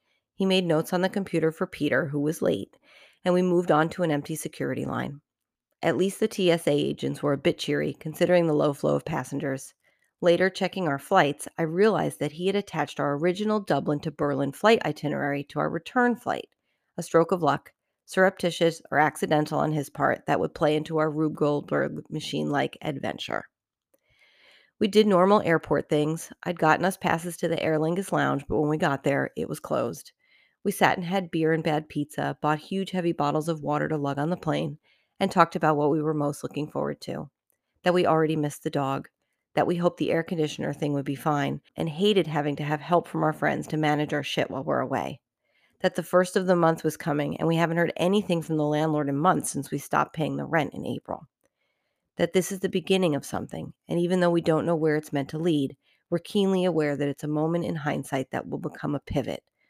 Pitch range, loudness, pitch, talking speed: 150-180 Hz, -26 LUFS, 160 Hz, 220 wpm